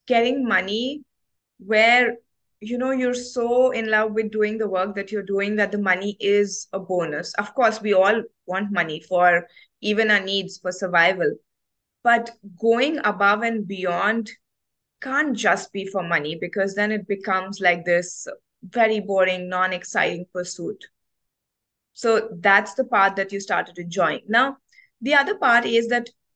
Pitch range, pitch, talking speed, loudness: 190-235 Hz, 205 Hz, 160 wpm, -21 LUFS